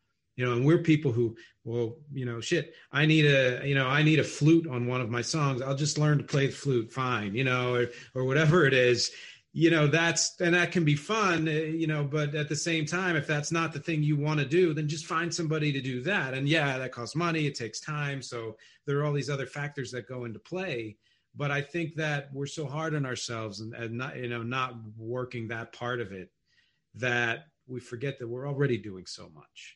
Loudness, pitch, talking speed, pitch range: -28 LUFS, 140 Hz, 240 wpm, 120-155 Hz